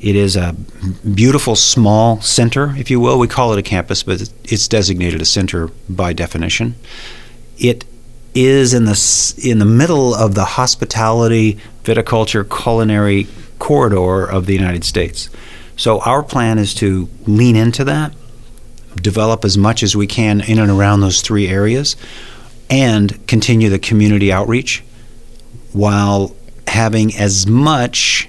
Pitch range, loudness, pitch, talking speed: 100-120 Hz, -13 LUFS, 110 Hz, 140 wpm